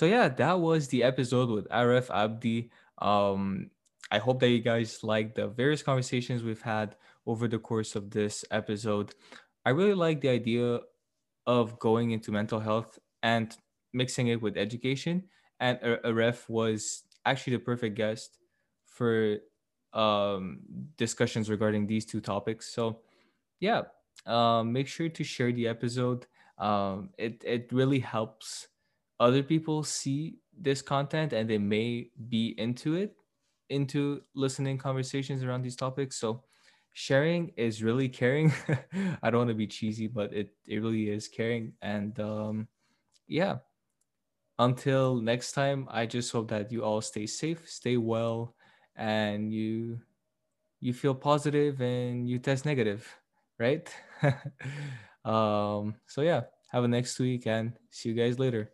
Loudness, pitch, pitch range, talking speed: -30 LUFS, 120 Hz, 110-135 Hz, 145 wpm